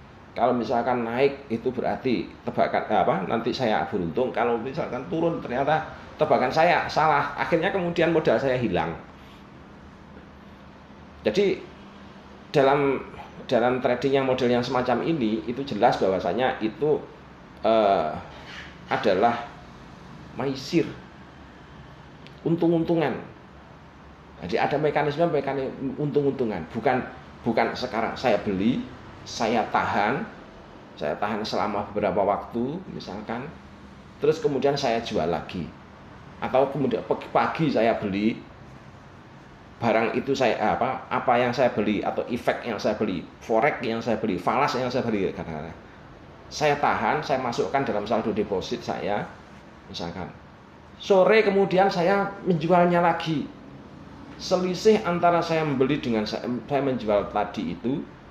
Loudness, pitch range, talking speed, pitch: -25 LUFS, 100-160 Hz, 115 wpm, 125 Hz